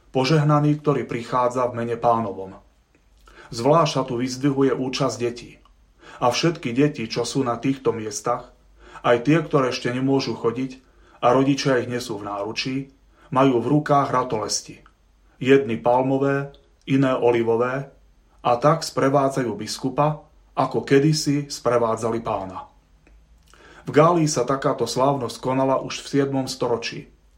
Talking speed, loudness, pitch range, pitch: 125 wpm, -22 LUFS, 120-140 Hz, 130 Hz